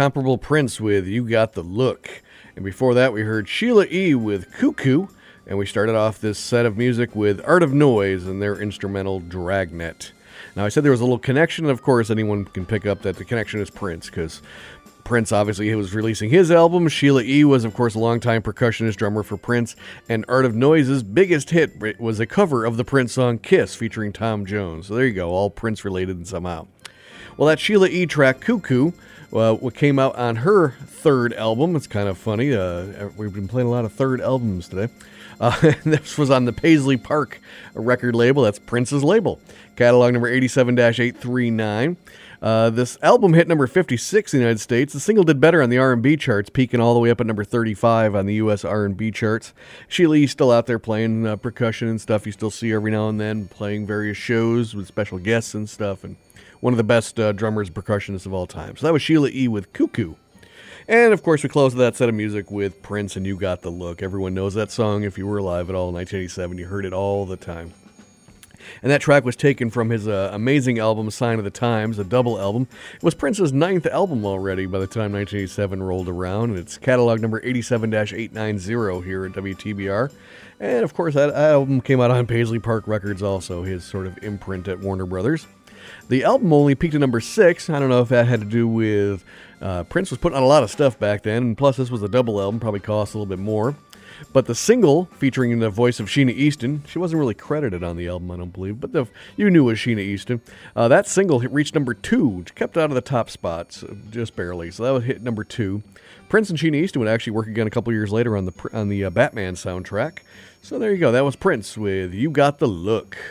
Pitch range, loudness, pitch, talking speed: 100-130 Hz, -20 LUFS, 115 Hz, 220 wpm